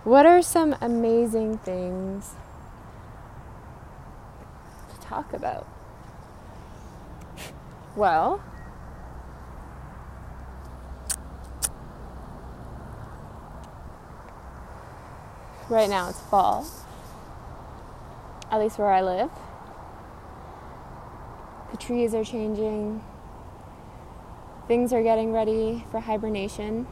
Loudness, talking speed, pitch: -25 LUFS, 60 wpm, 190 Hz